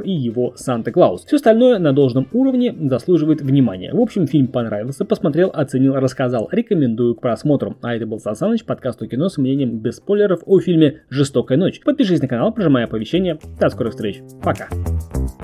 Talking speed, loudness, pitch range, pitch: 180 wpm, -18 LUFS, 120-180 Hz, 135 Hz